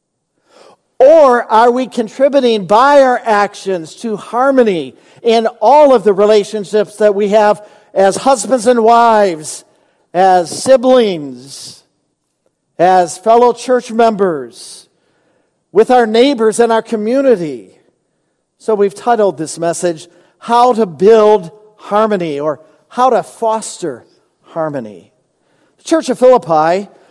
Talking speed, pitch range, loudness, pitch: 115 wpm, 190-240 Hz, -11 LUFS, 215 Hz